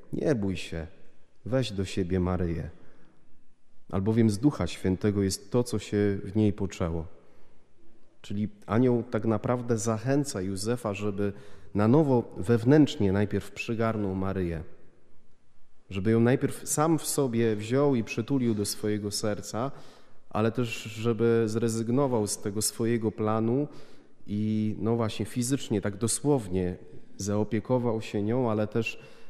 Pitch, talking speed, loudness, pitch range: 110 Hz, 125 wpm, -28 LUFS, 100-120 Hz